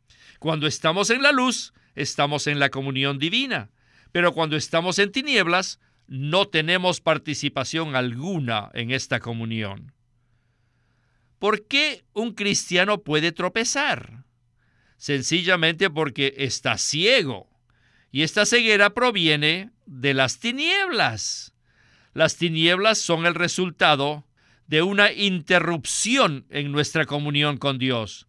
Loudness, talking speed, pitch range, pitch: -21 LUFS, 110 wpm, 130-185 Hz, 155 Hz